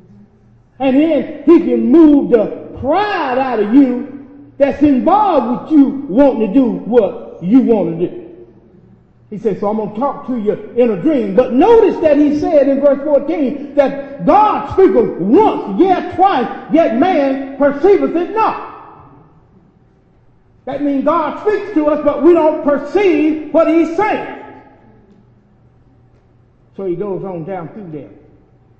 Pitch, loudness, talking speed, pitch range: 280 Hz, -13 LUFS, 150 wpm, 240-330 Hz